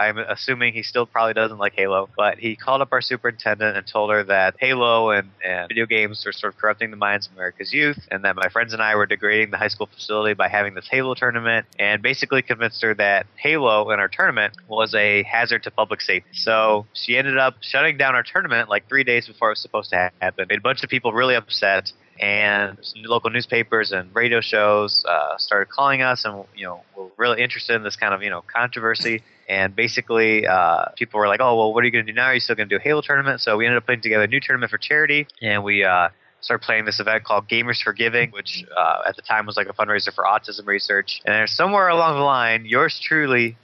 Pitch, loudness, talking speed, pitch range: 110 Hz, -19 LUFS, 245 wpm, 105-120 Hz